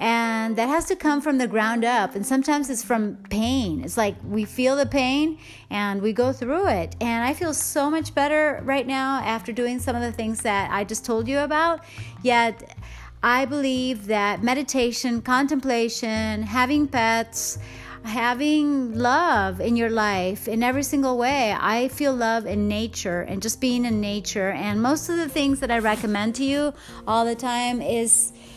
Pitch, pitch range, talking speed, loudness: 240 Hz, 220-275 Hz, 180 wpm, -23 LUFS